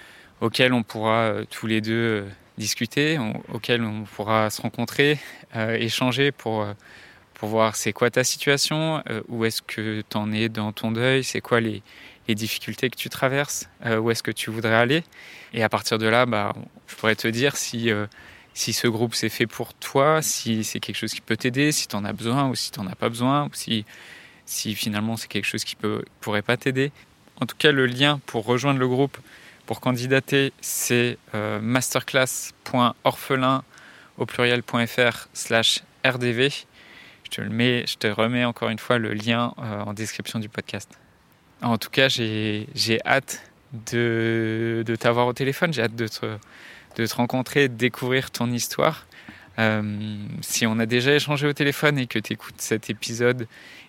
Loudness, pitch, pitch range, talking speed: -23 LUFS, 115 Hz, 110-130 Hz, 185 wpm